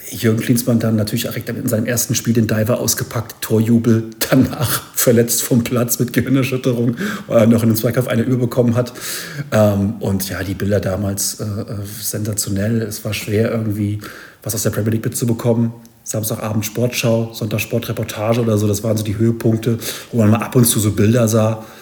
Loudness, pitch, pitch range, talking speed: -17 LUFS, 115 Hz, 110-120 Hz, 180 wpm